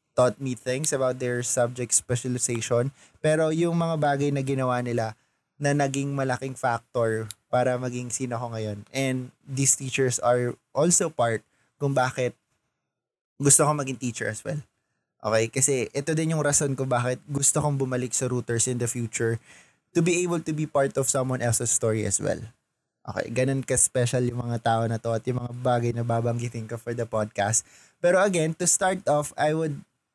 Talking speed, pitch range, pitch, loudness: 180 wpm, 120-140 Hz, 125 Hz, -25 LUFS